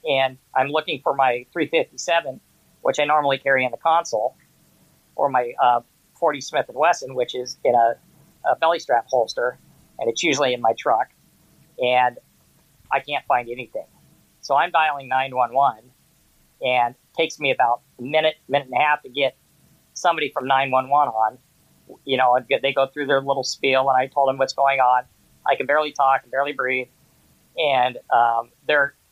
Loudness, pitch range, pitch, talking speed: -21 LUFS, 125-140 Hz, 135 Hz, 175 wpm